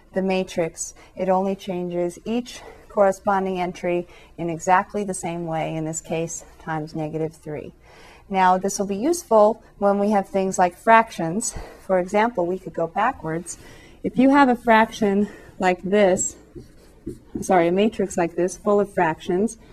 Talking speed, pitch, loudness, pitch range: 155 wpm, 185 Hz, -22 LUFS, 175-205 Hz